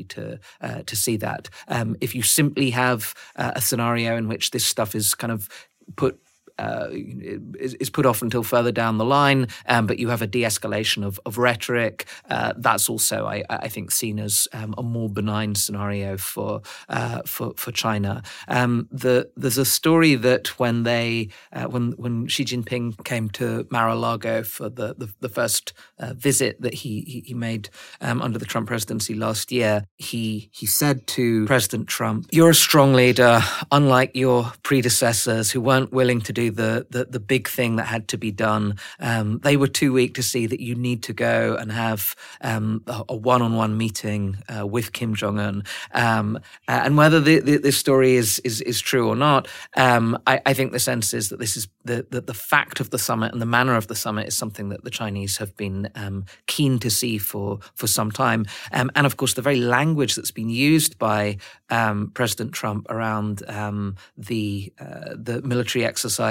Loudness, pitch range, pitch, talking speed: -21 LUFS, 110-125 Hz, 115 Hz, 195 wpm